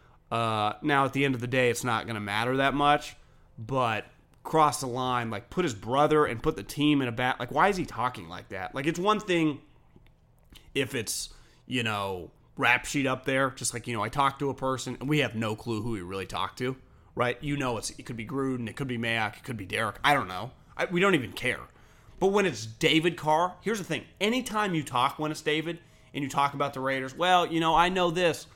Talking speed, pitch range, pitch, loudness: 250 wpm, 115-150 Hz, 130 Hz, -28 LUFS